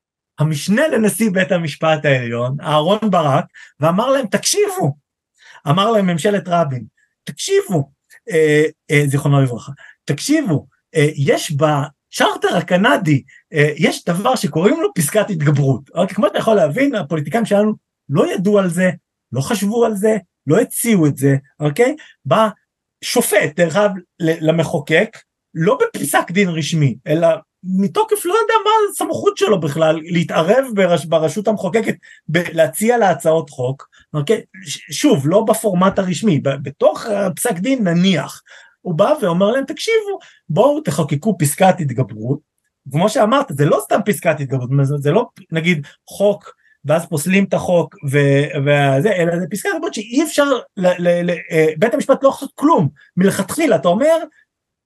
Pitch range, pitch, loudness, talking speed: 155-220 Hz, 180 Hz, -16 LUFS, 145 wpm